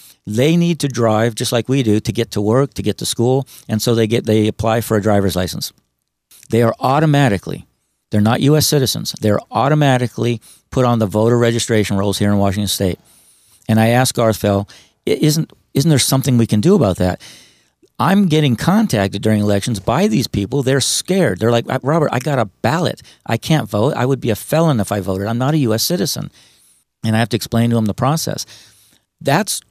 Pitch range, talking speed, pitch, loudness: 105-140 Hz, 205 wpm, 115 Hz, -16 LUFS